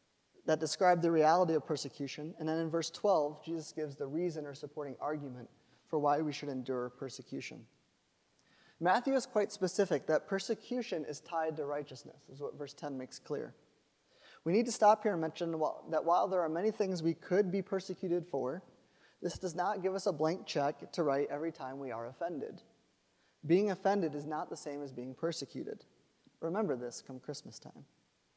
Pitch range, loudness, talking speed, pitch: 145-185 Hz, -35 LUFS, 185 wpm, 160 Hz